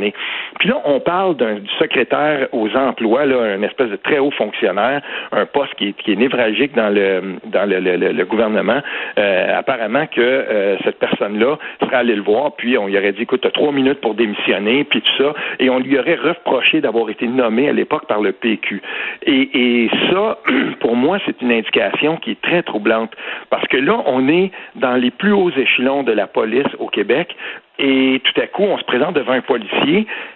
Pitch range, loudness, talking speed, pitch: 115-145 Hz, -16 LUFS, 205 wpm, 130 Hz